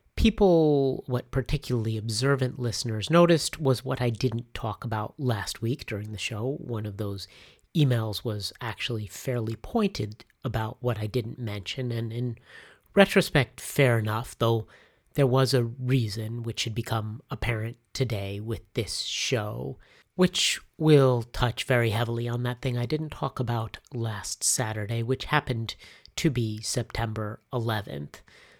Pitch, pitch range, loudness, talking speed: 120 Hz, 110-130 Hz, -27 LUFS, 145 wpm